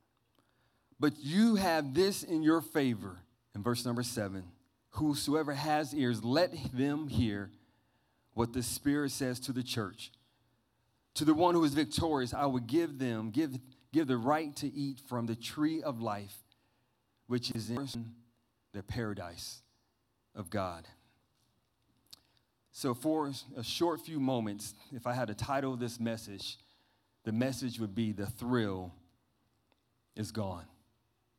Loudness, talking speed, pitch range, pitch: -34 LUFS, 140 wpm, 115-140 Hz, 120 Hz